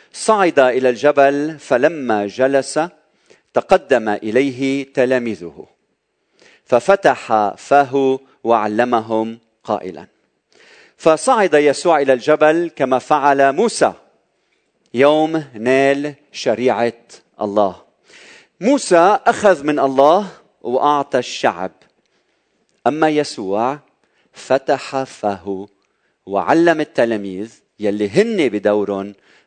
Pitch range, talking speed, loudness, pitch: 115-155 Hz, 75 wpm, -16 LUFS, 135 Hz